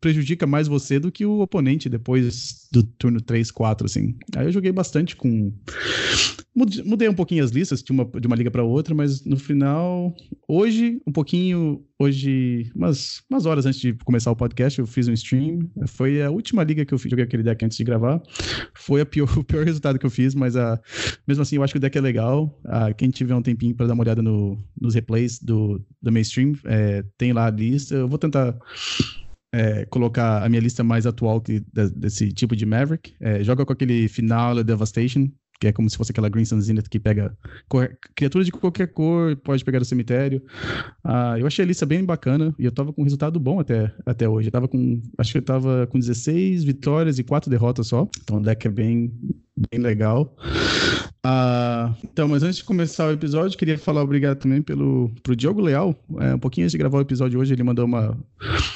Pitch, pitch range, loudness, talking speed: 130 Hz, 115-145 Hz, -21 LUFS, 215 wpm